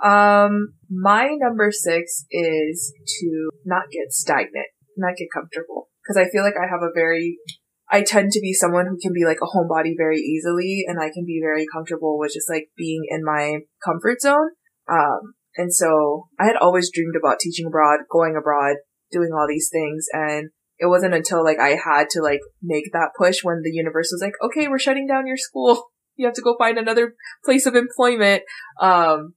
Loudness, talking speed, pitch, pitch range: -20 LUFS, 195 wpm, 170 Hz, 155-205 Hz